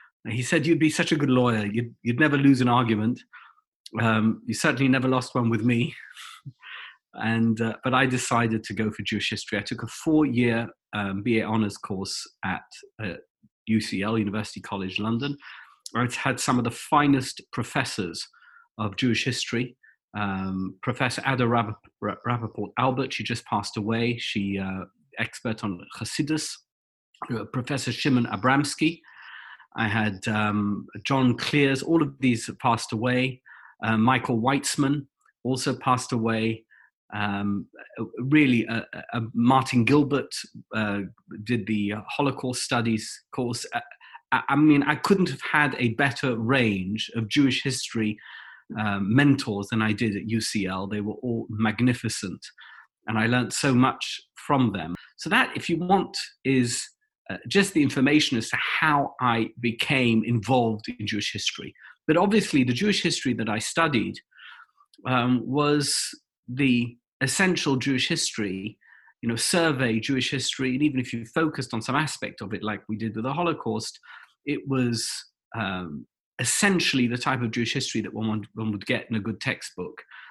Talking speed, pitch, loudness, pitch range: 155 wpm, 120 Hz, -25 LUFS, 110-140 Hz